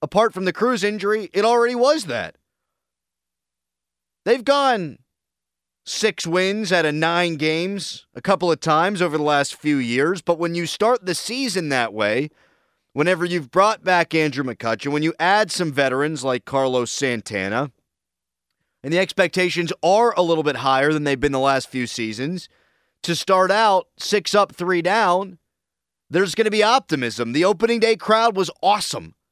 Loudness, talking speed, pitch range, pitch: -20 LUFS, 165 wpm, 135-195 Hz, 170 Hz